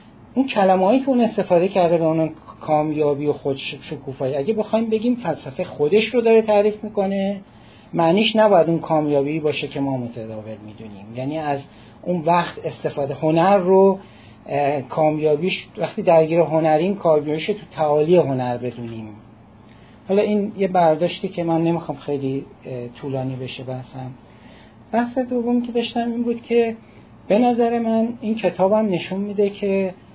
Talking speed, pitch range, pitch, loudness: 140 wpm, 135-205 Hz, 160 Hz, -20 LUFS